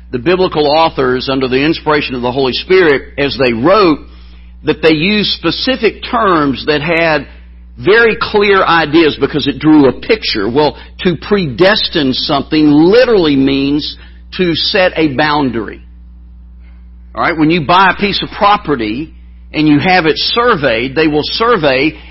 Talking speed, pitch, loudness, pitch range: 150 wpm, 150 Hz, -11 LUFS, 130-185 Hz